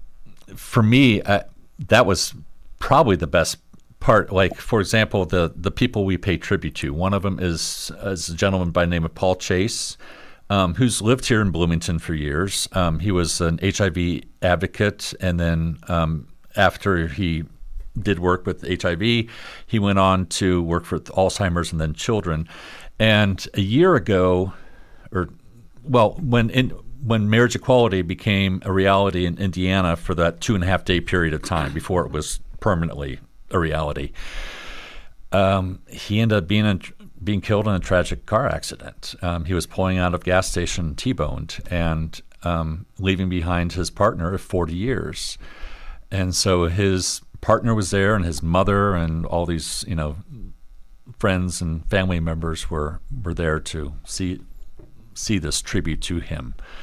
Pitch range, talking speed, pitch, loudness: 85-100 Hz, 165 wpm, 90 Hz, -21 LUFS